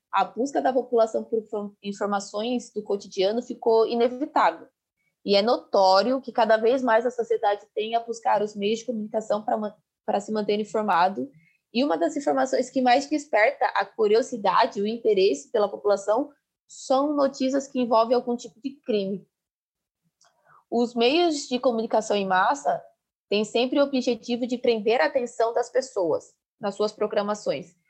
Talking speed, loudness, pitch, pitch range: 155 wpm, -24 LUFS, 230 Hz, 205-255 Hz